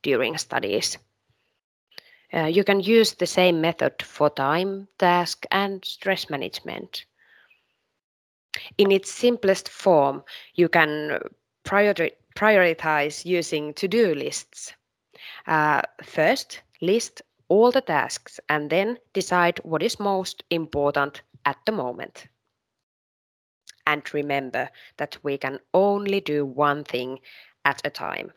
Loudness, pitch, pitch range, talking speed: -23 LUFS, 175 Hz, 150-200 Hz, 115 wpm